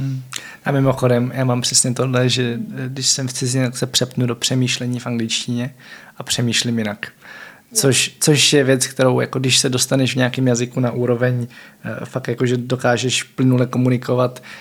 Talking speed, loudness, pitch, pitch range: 165 wpm, -18 LUFS, 125 Hz, 120-130 Hz